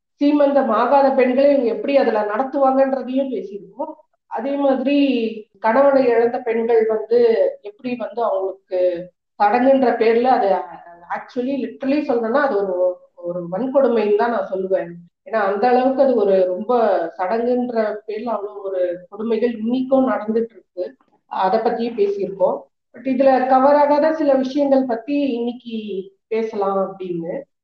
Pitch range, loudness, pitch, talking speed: 200-270 Hz, -18 LUFS, 235 Hz, 120 wpm